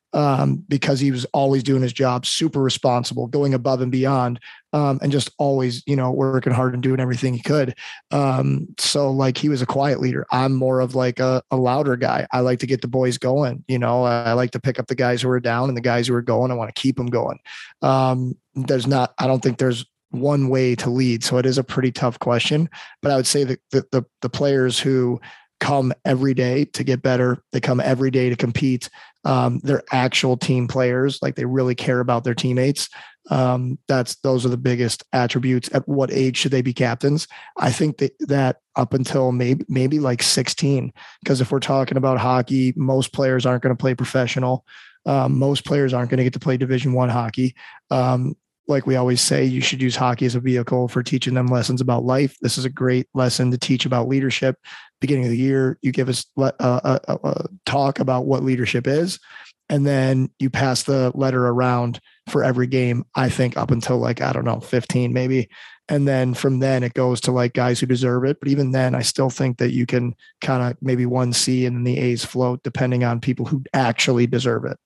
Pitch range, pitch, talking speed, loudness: 125-135 Hz, 130 Hz, 220 wpm, -20 LUFS